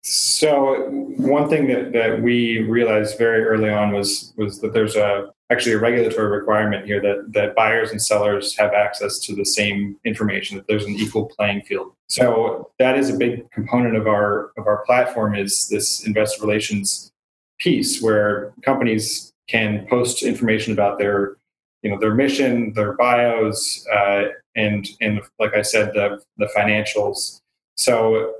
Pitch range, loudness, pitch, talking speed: 105-115 Hz, -19 LUFS, 105 Hz, 160 wpm